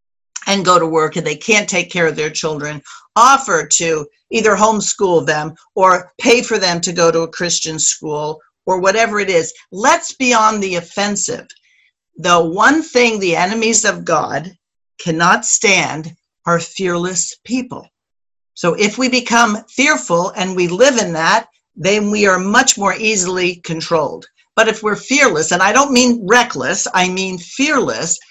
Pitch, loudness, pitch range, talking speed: 185 Hz, -14 LUFS, 170-225 Hz, 165 wpm